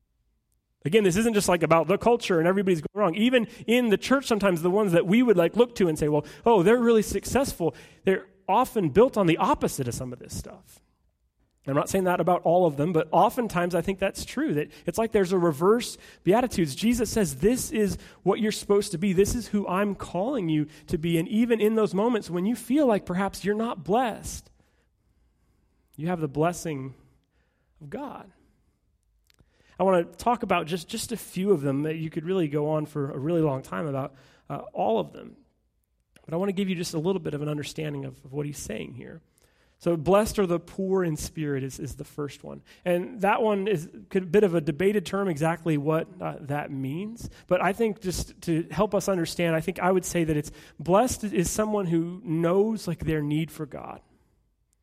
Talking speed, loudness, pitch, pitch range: 215 wpm, -25 LUFS, 180 Hz, 160-205 Hz